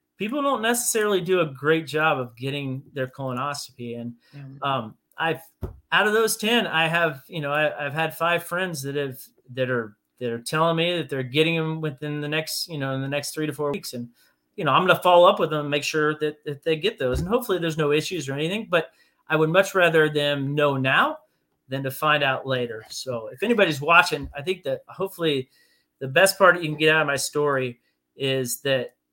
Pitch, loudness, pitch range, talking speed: 150 Hz, -23 LUFS, 135-170 Hz, 225 wpm